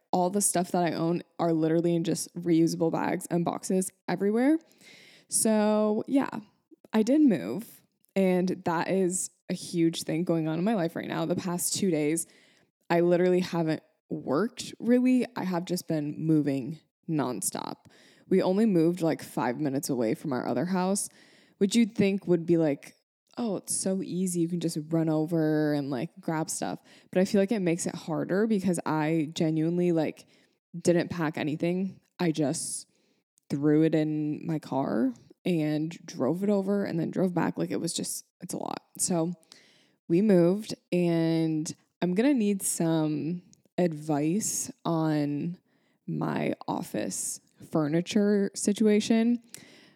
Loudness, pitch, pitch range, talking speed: -28 LUFS, 170 Hz, 160-195 Hz, 155 wpm